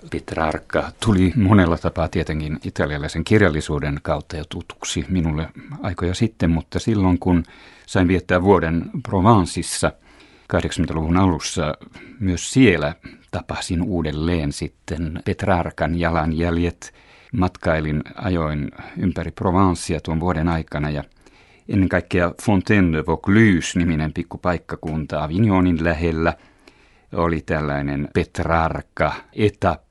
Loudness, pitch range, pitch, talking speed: -21 LUFS, 80-95 Hz, 85 Hz, 100 wpm